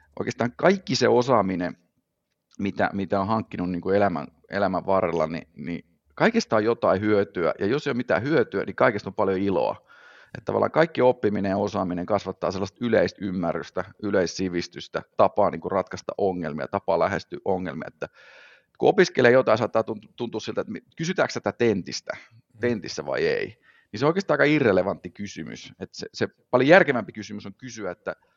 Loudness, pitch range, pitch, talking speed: -24 LUFS, 100-120 Hz, 110 Hz, 165 wpm